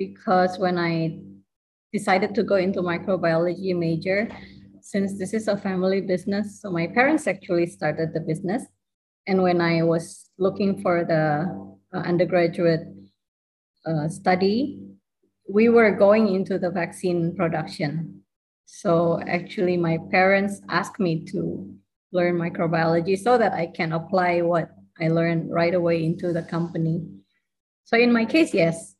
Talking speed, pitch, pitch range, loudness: 135 wpm, 175 Hz, 165-195 Hz, -23 LUFS